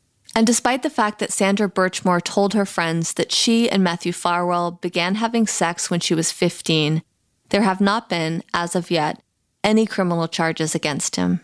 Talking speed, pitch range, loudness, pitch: 180 wpm, 170-205 Hz, -20 LUFS, 180 Hz